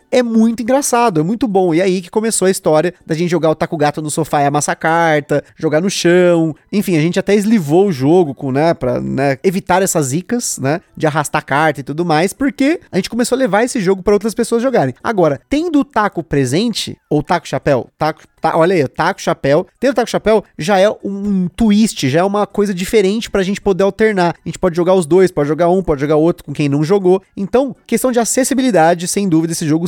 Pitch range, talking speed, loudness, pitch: 155-210 Hz, 230 wpm, -14 LUFS, 180 Hz